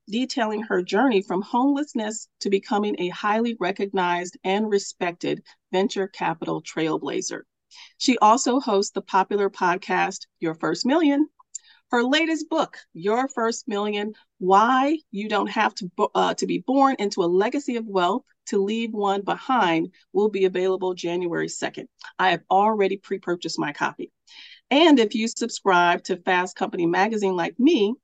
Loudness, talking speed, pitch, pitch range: -23 LUFS, 150 wpm, 205 Hz, 190-235 Hz